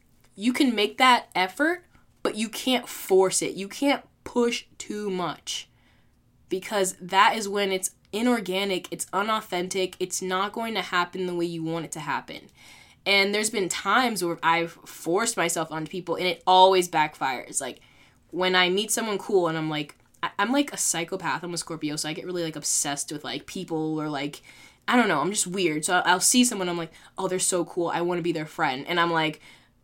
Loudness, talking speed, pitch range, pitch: -25 LUFS, 200 wpm, 165-200 Hz, 185 Hz